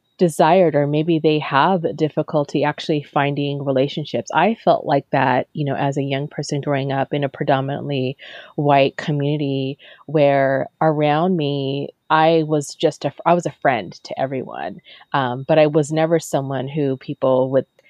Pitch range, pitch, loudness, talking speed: 140-155 Hz, 145 Hz, -19 LUFS, 160 wpm